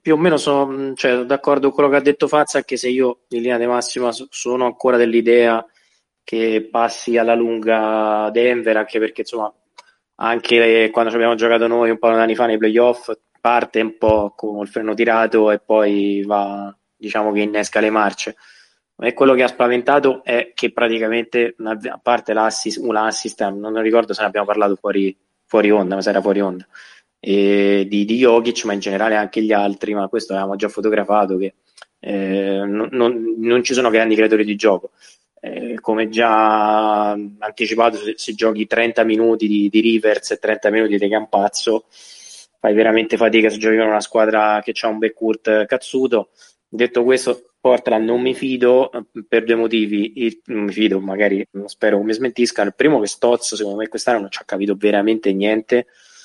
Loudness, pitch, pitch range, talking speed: -17 LUFS, 110 Hz, 105-120 Hz, 185 wpm